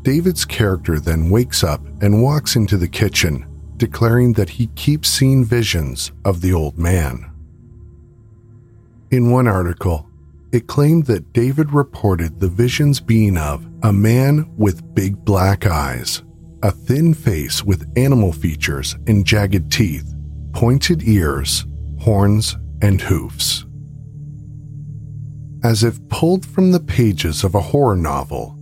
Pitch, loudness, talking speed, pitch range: 105 Hz, -17 LUFS, 130 wpm, 80-125 Hz